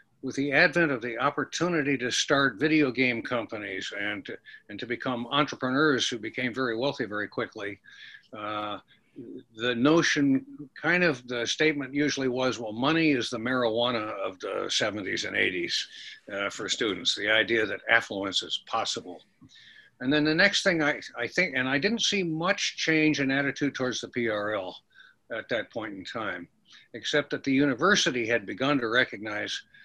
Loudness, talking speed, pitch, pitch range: -27 LUFS, 165 wpm, 145 Hz, 125-175 Hz